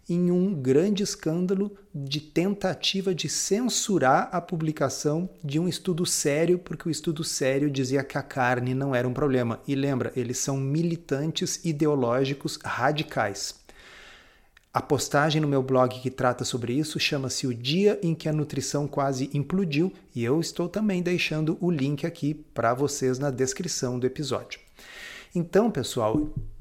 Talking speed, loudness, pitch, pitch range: 150 wpm, -26 LUFS, 150 Hz, 135-175 Hz